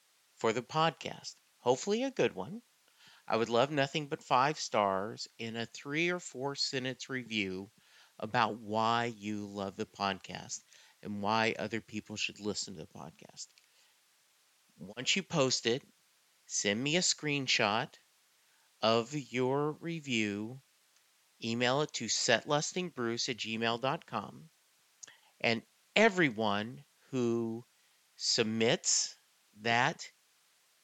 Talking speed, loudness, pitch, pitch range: 115 wpm, -33 LUFS, 120 Hz, 110-145 Hz